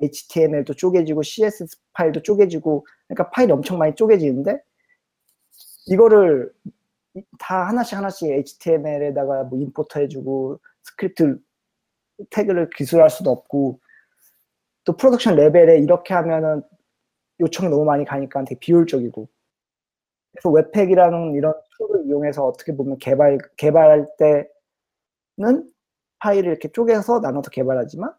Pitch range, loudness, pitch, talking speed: 145-200 Hz, -18 LUFS, 160 Hz, 320 characters per minute